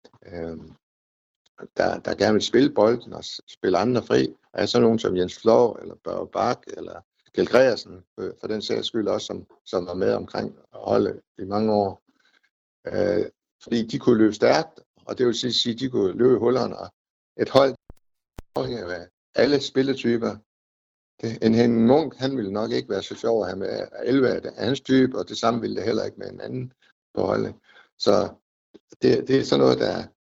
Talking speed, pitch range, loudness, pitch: 195 wpm, 90-130 Hz, -23 LUFS, 115 Hz